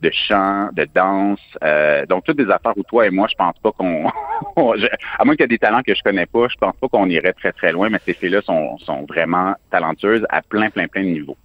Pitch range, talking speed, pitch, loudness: 85-105 Hz, 255 wpm, 100 Hz, -17 LUFS